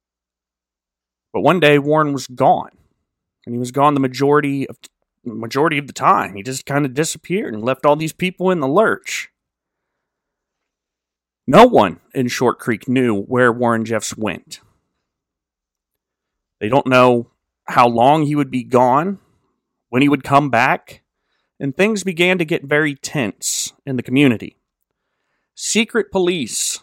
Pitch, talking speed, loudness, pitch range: 135 Hz, 150 wpm, -16 LUFS, 120-150 Hz